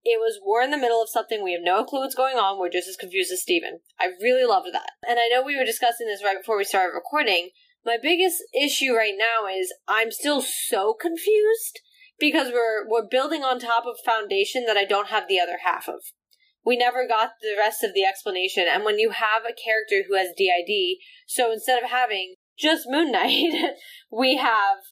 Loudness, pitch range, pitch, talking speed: -23 LUFS, 215-355 Hz, 245 Hz, 215 wpm